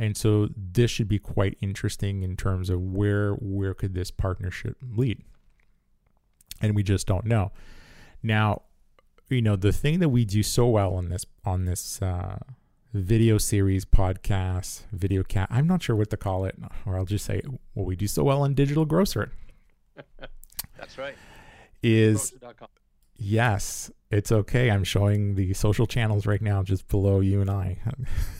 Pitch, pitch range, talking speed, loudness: 105 Hz, 95-115 Hz, 165 wpm, -26 LUFS